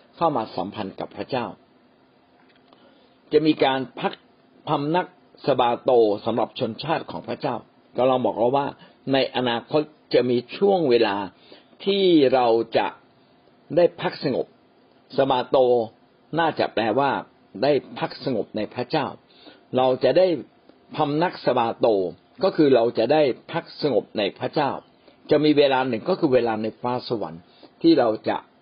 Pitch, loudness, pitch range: 130 Hz, -22 LUFS, 115-155 Hz